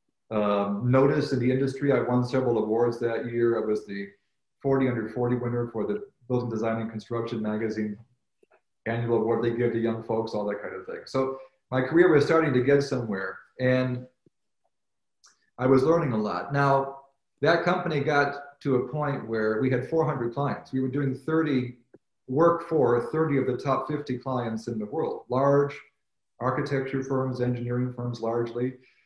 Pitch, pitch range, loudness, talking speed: 125 Hz, 115-135 Hz, -26 LUFS, 175 wpm